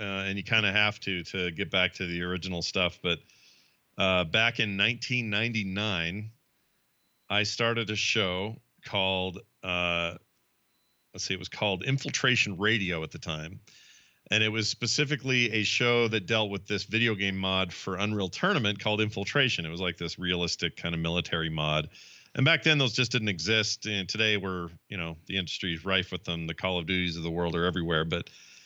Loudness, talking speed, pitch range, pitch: -28 LUFS, 190 wpm, 85-110 Hz, 95 Hz